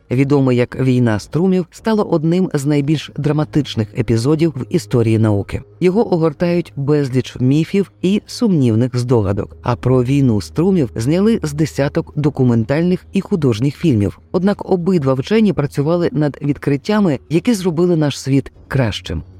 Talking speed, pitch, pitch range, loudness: 130 wpm, 145 Hz, 125-175 Hz, -16 LUFS